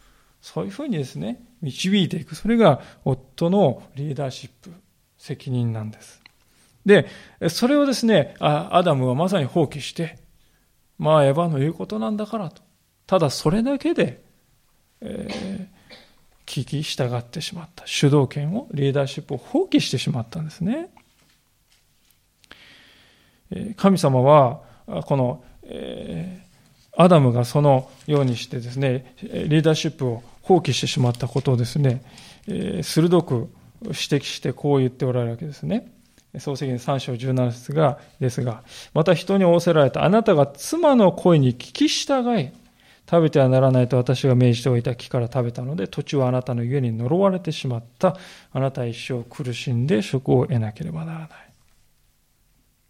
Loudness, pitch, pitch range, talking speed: -21 LUFS, 145 Hz, 130-180 Hz, 300 characters per minute